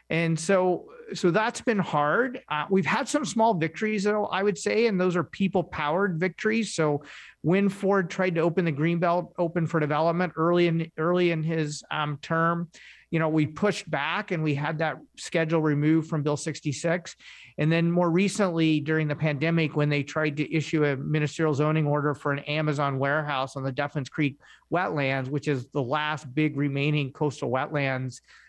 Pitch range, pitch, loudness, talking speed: 150-180 Hz, 160 Hz, -26 LUFS, 180 wpm